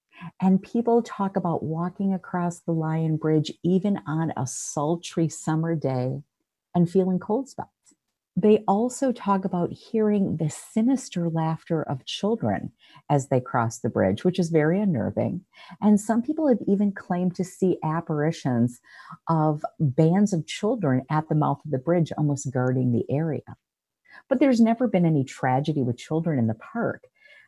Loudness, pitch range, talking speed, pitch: -25 LUFS, 150-200 Hz, 155 wpm, 170 Hz